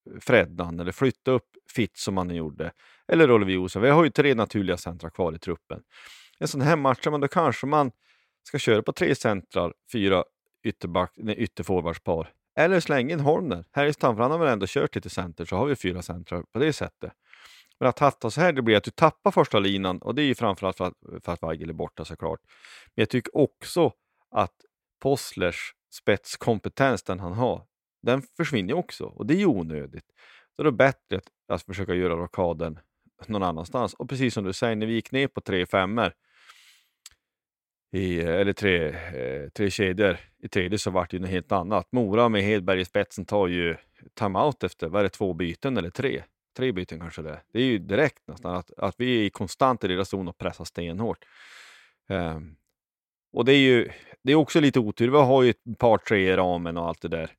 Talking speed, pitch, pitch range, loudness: 205 wpm, 100 Hz, 90-125 Hz, -25 LUFS